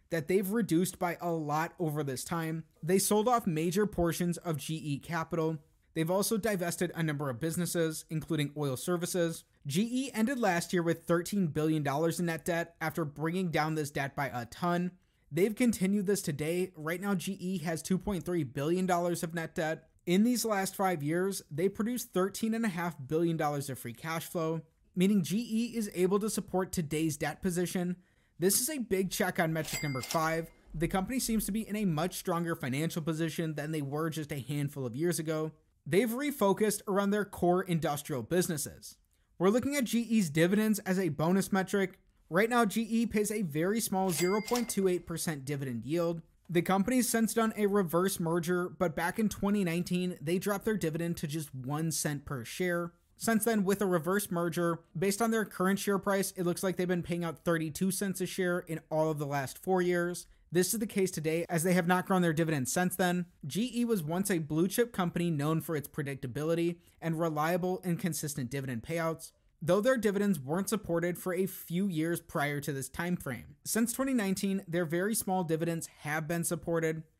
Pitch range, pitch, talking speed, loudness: 160-195 Hz, 175 Hz, 185 wpm, -32 LUFS